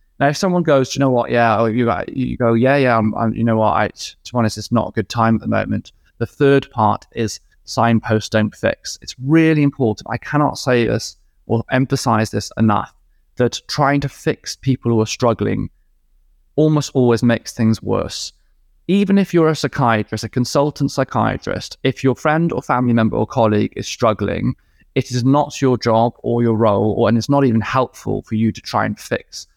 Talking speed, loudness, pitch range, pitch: 200 wpm, -17 LUFS, 110-135 Hz, 115 Hz